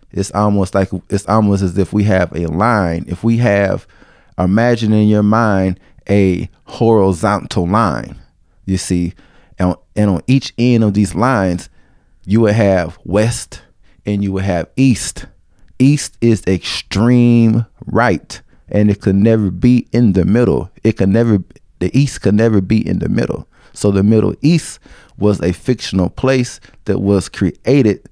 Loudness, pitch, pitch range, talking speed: -14 LUFS, 100 Hz, 95-115 Hz, 160 wpm